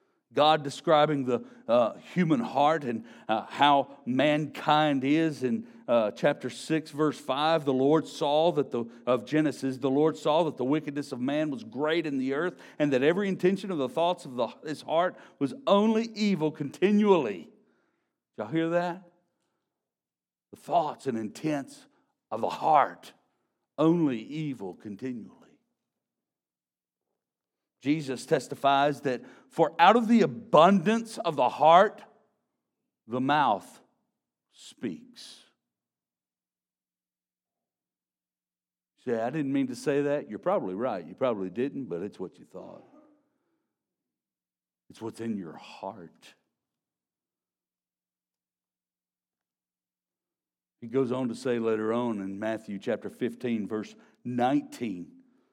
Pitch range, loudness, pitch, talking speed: 105-165 Hz, -27 LUFS, 140 Hz, 125 wpm